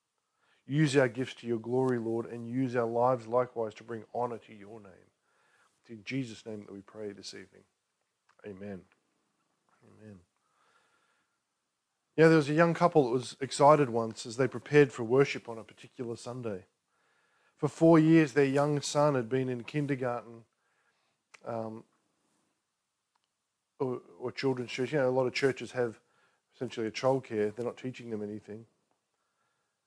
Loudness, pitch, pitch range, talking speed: -29 LUFS, 120 Hz, 110-135 Hz, 160 wpm